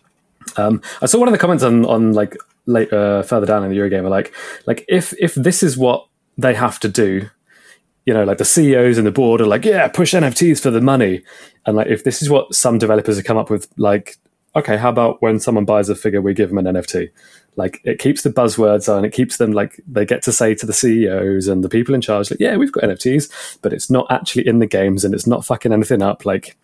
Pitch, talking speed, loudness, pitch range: 110 Hz, 250 wpm, -15 LUFS, 105-125 Hz